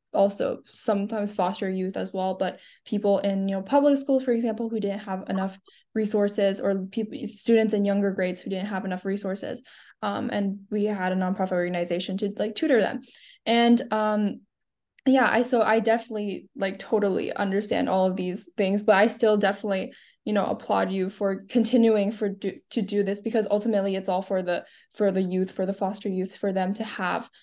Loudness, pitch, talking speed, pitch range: -25 LUFS, 200 Hz, 195 wpm, 190-220 Hz